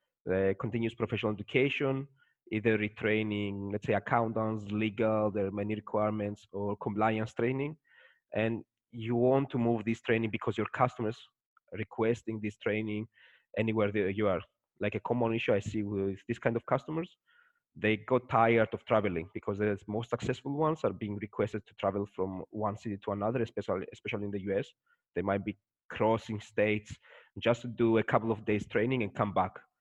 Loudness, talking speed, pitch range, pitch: -32 LUFS, 175 wpm, 105-115 Hz, 110 Hz